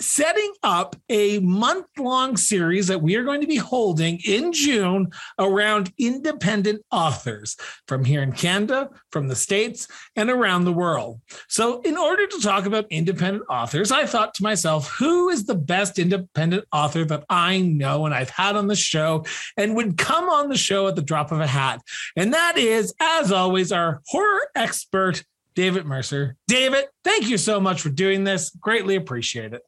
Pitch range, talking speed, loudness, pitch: 165-235 Hz, 180 wpm, -21 LUFS, 195 Hz